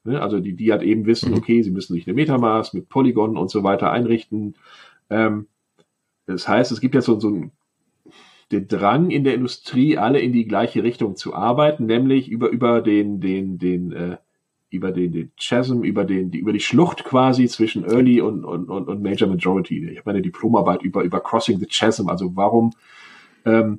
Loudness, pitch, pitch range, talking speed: -19 LUFS, 110 Hz, 95-120 Hz, 190 wpm